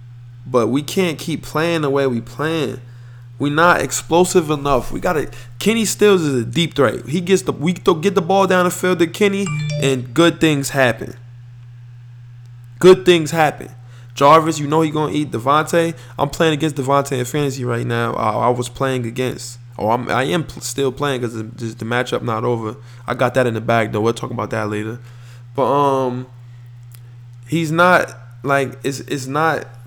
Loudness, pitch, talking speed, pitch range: -17 LUFS, 130 Hz, 185 wpm, 120-160 Hz